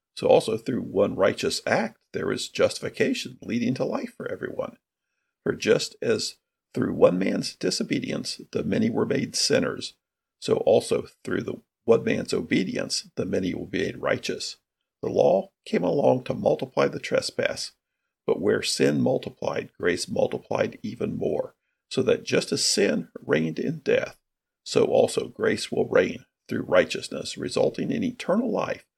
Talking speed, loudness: 155 wpm, -25 LUFS